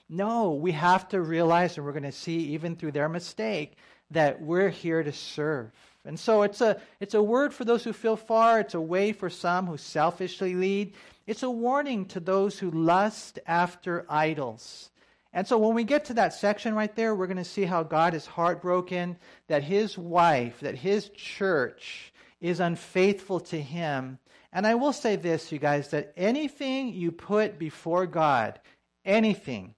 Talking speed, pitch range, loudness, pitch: 180 wpm, 165-210 Hz, -27 LUFS, 180 Hz